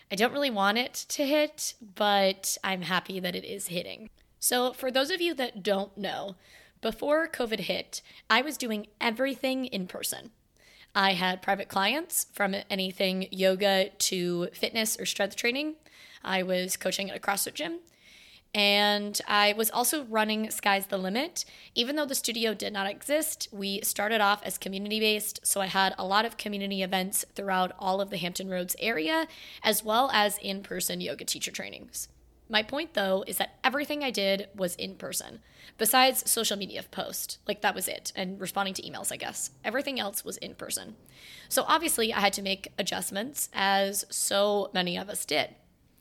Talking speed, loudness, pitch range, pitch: 180 wpm, -28 LUFS, 195-245 Hz, 205 Hz